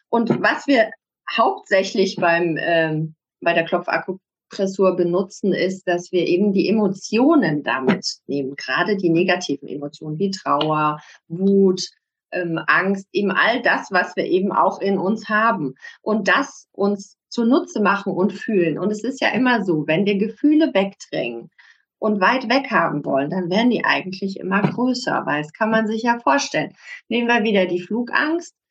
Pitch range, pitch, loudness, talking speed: 175-225 Hz, 195 Hz, -20 LUFS, 160 wpm